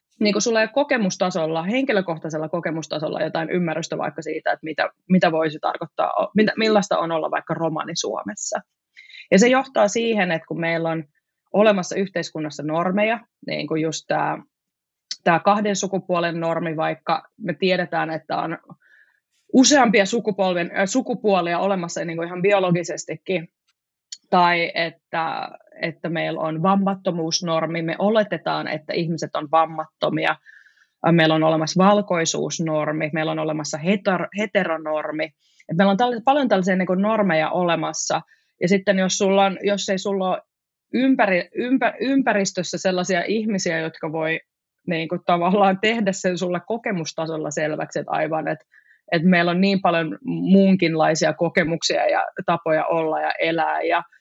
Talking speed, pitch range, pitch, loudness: 135 wpm, 160-200 Hz, 180 Hz, -21 LUFS